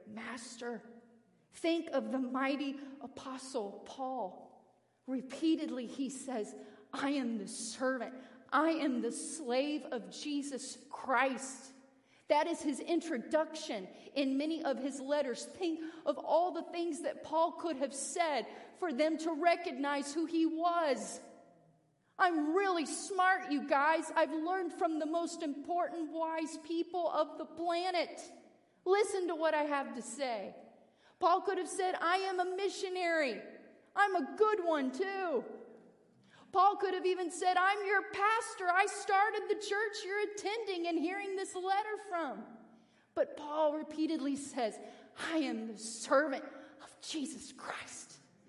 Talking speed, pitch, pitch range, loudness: 140 wpm, 315 Hz, 270-350 Hz, -35 LUFS